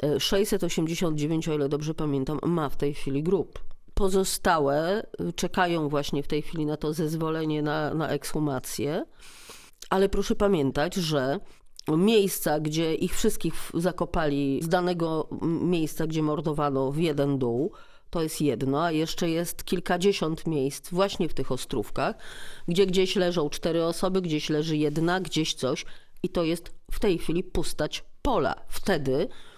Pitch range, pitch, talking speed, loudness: 150-180 Hz, 160 Hz, 140 wpm, -27 LUFS